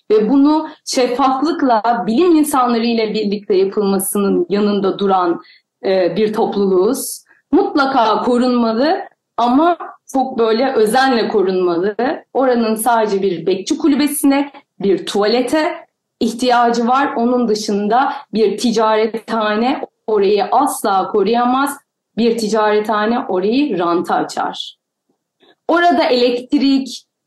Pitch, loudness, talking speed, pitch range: 235 Hz, -15 LUFS, 95 wpm, 210-275 Hz